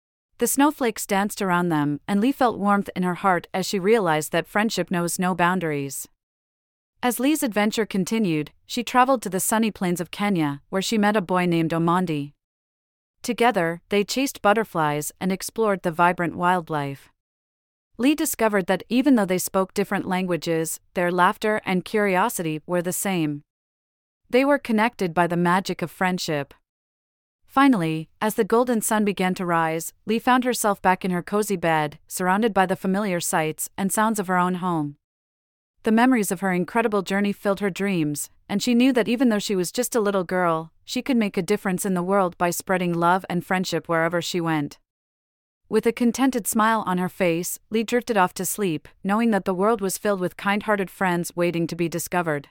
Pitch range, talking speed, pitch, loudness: 170-215 Hz, 185 wpm, 185 Hz, -23 LUFS